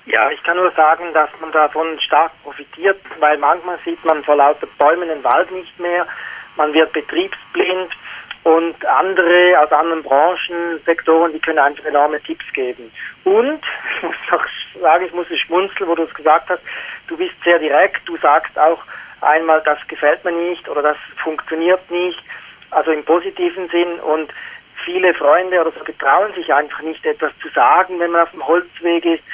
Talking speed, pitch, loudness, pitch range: 180 wpm, 165 Hz, -16 LUFS, 155-180 Hz